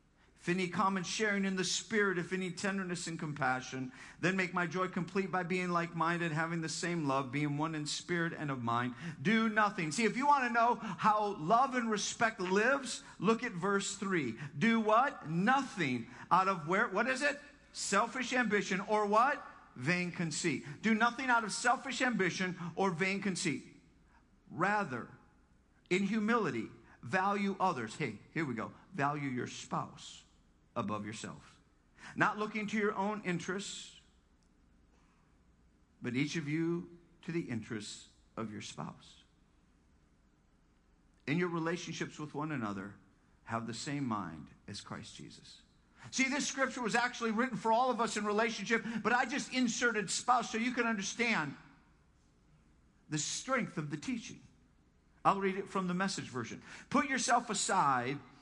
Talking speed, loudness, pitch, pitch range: 155 wpm, -34 LUFS, 185 Hz, 145-220 Hz